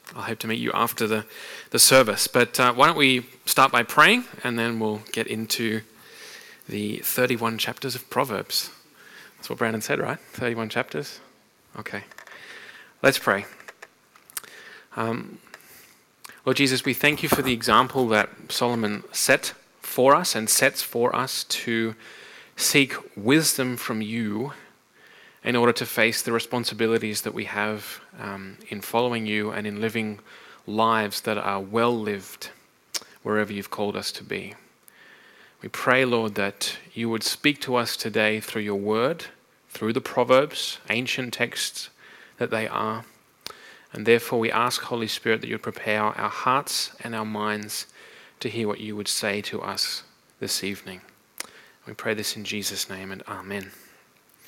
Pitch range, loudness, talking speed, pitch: 105-125 Hz, -24 LUFS, 155 wpm, 115 Hz